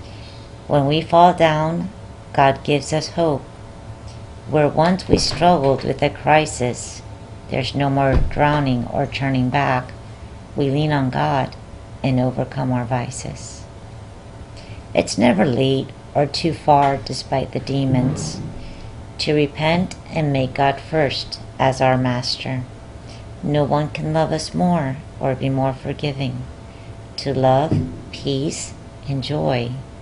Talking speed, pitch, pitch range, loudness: 125 wpm, 130 Hz, 110-145 Hz, -19 LUFS